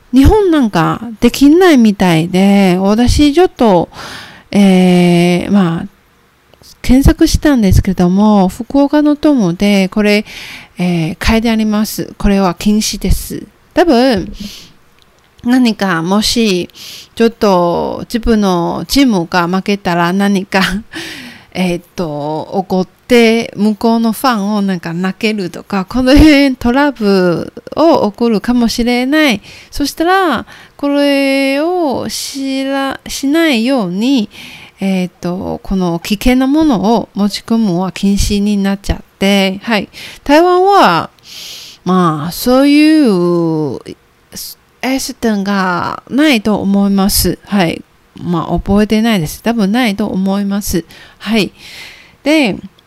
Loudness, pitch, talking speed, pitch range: -12 LUFS, 210 Hz, 235 characters per minute, 185-255 Hz